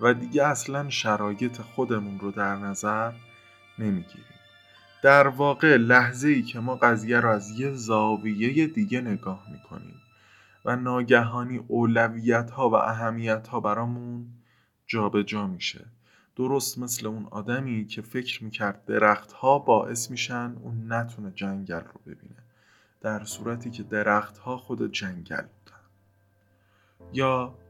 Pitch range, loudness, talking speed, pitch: 105-125 Hz, -25 LUFS, 125 wpm, 115 Hz